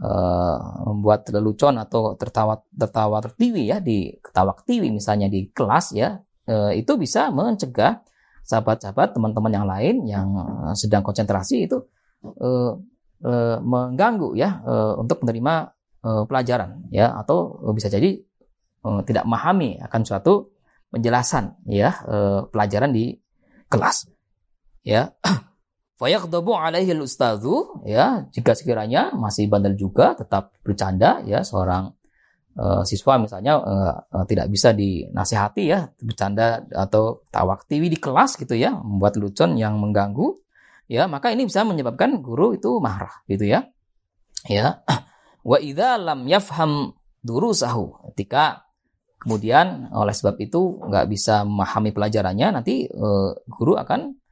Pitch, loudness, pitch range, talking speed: 110 Hz, -21 LUFS, 100-135 Hz, 125 wpm